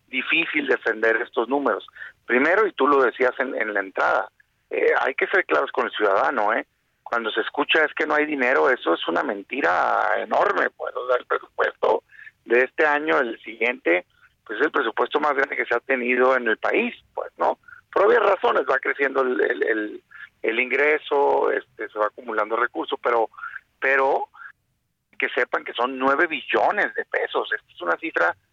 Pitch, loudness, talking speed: 175 Hz, -22 LUFS, 185 wpm